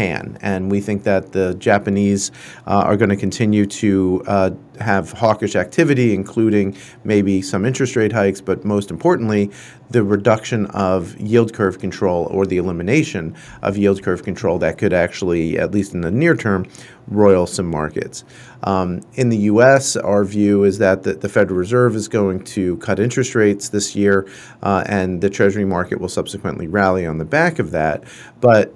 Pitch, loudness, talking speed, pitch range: 100 Hz, -17 LUFS, 175 wpm, 95-110 Hz